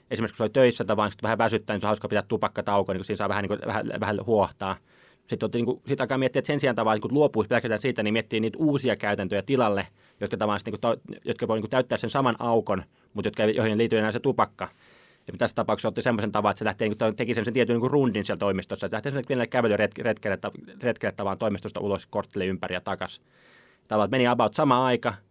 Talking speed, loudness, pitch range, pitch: 220 wpm, -26 LUFS, 105-120 Hz, 110 Hz